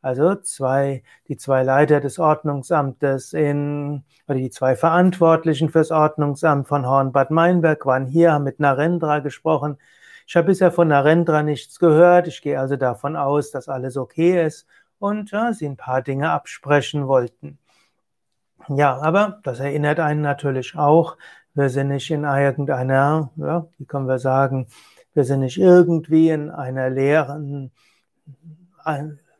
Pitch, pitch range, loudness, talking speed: 145 Hz, 135-160 Hz, -19 LUFS, 145 wpm